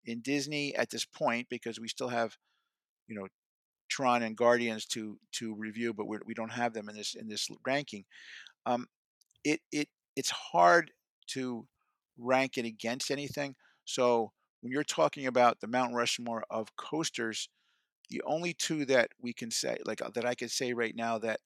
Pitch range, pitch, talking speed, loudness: 115-130 Hz, 120 Hz, 175 wpm, -33 LUFS